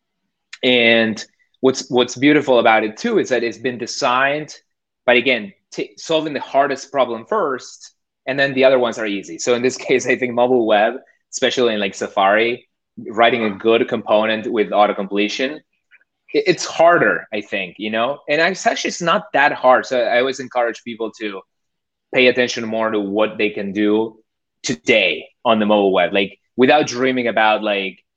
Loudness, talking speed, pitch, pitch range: -17 LUFS, 175 wpm, 120 Hz, 110-130 Hz